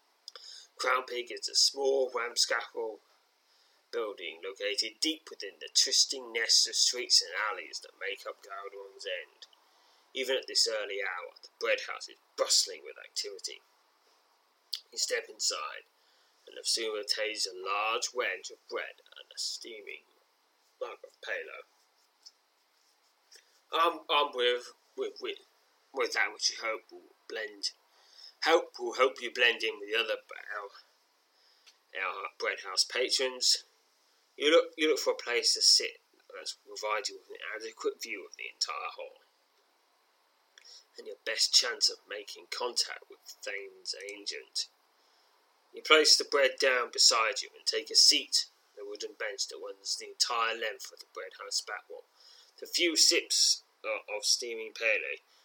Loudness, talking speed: -29 LUFS, 155 wpm